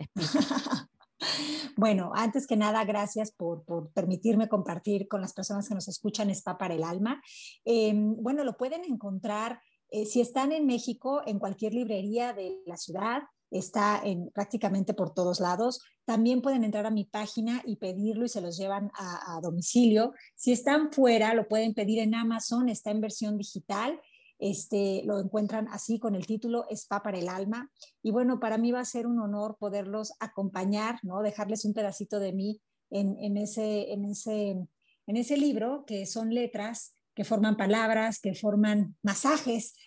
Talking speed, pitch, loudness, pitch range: 170 wpm, 215 Hz, -30 LUFS, 200-235 Hz